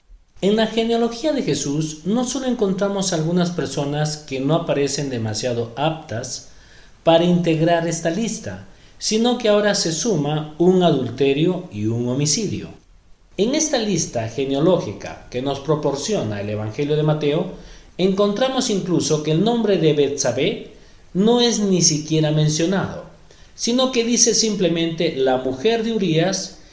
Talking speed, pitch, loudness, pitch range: 135 wpm, 165 Hz, -19 LUFS, 140-205 Hz